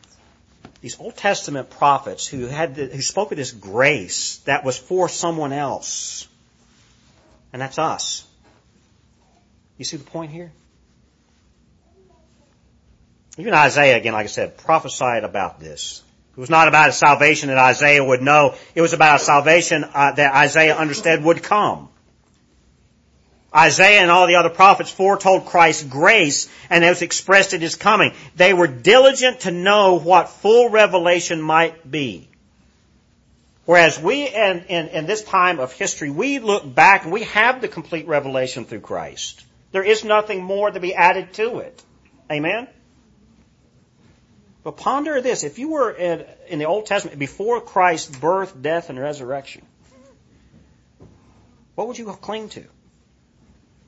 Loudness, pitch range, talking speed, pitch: -16 LUFS, 140-190 Hz, 150 wpm, 165 Hz